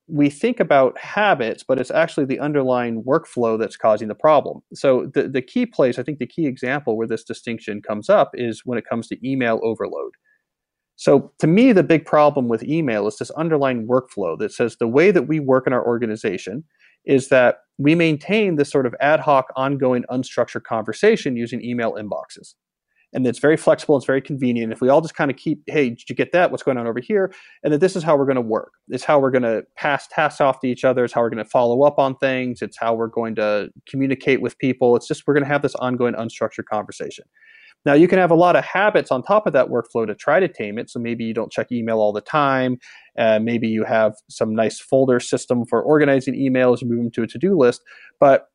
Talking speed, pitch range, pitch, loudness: 235 wpm, 115-150 Hz, 130 Hz, -19 LUFS